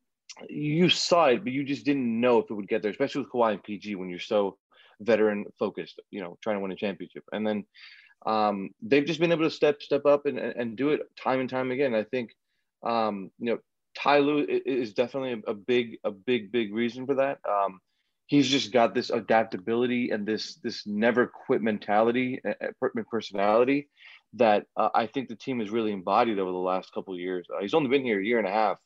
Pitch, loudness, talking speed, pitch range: 115 Hz, -27 LUFS, 220 wpm, 105-135 Hz